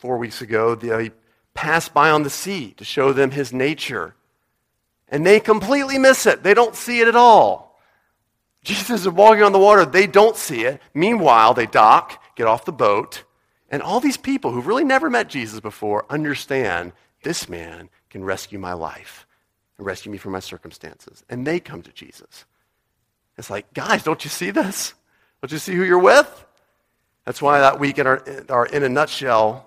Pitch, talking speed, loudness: 140 Hz, 190 wpm, -17 LUFS